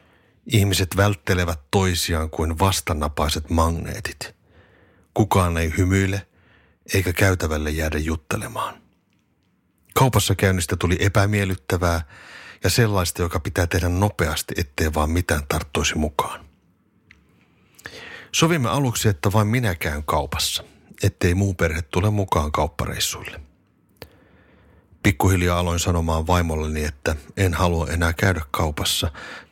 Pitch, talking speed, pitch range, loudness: 90 Hz, 105 wpm, 85-100 Hz, -22 LUFS